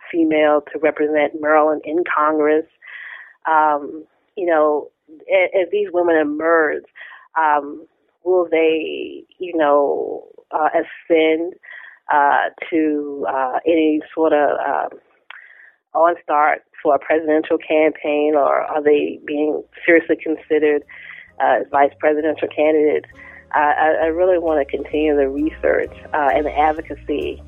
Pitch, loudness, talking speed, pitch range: 155 Hz, -18 LUFS, 125 wpm, 150-165 Hz